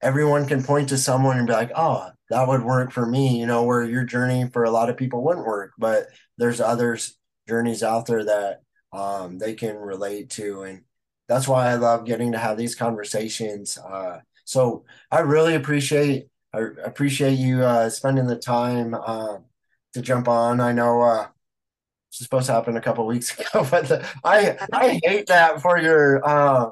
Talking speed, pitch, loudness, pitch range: 190 wpm, 120 Hz, -21 LUFS, 115-135 Hz